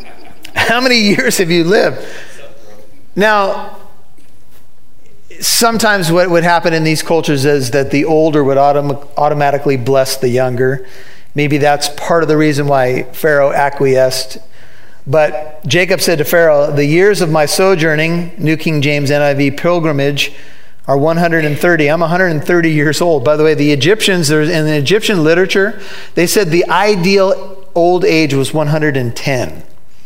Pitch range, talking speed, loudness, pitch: 145-180 Hz, 140 wpm, -12 LUFS, 155 Hz